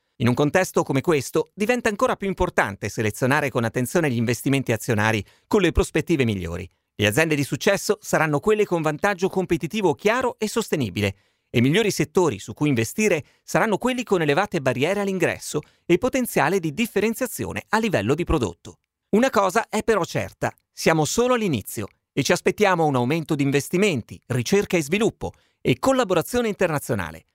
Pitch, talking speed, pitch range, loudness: 160 Hz, 160 wpm, 120-205 Hz, -22 LUFS